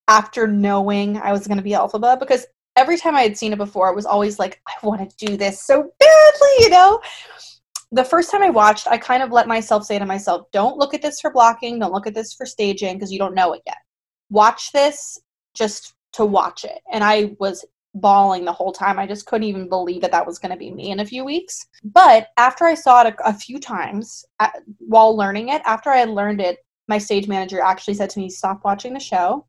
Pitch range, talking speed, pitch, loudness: 200-255 Hz, 240 wpm, 215 Hz, -16 LUFS